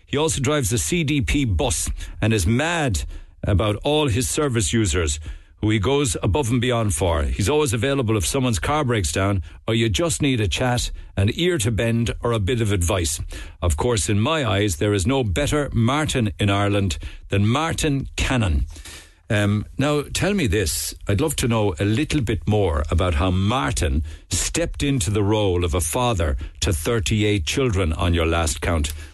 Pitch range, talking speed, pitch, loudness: 90-125 Hz, 185 wpm, 105 Hz, -21 LUFS